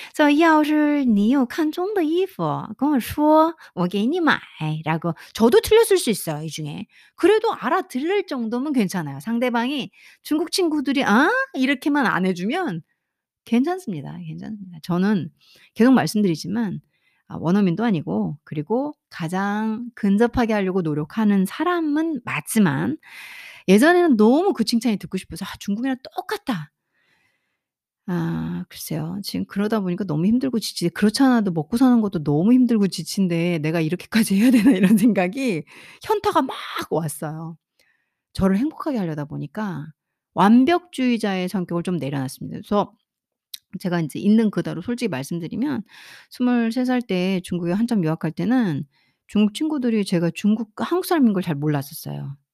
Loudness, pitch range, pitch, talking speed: -21 LUFS, 175-265 Hz, 215 Hz, 330 characters per minute